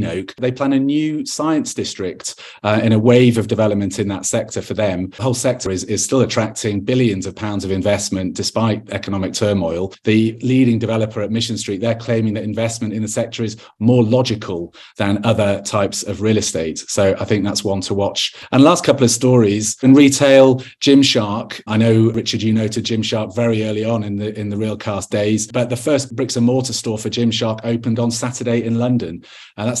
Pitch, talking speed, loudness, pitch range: 110 Hz, 205 wpm, -17 LUFS, 105-120 Hz